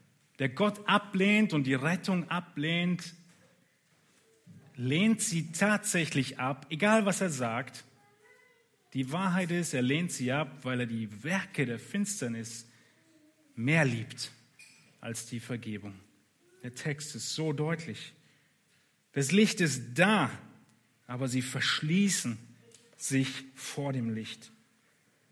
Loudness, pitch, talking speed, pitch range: -31 LUFS, 145 Hz, 115 wpm, 125-180 Hz